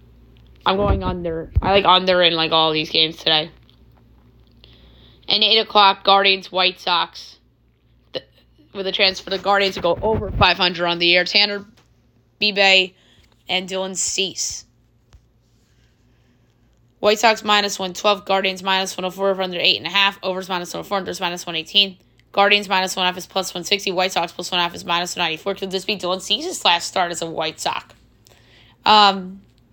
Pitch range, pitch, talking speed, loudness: 120-195 Hz, 180 Hz, 160 wpm, -18 LUFS